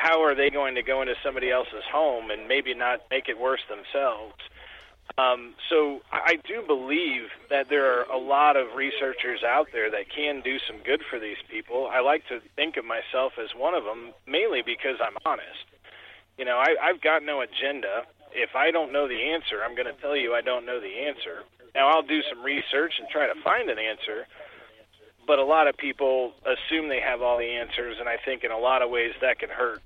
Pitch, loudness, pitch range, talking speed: 140 Hz, -26 LUFS, 125-160 Hz, 220 wpm